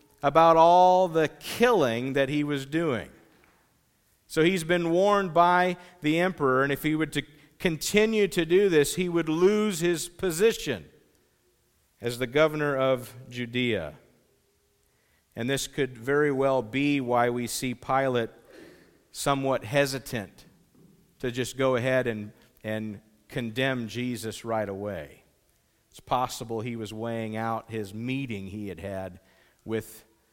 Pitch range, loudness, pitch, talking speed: 115-160 Hz, -26 LUFS, 135 Hz, 135 wpm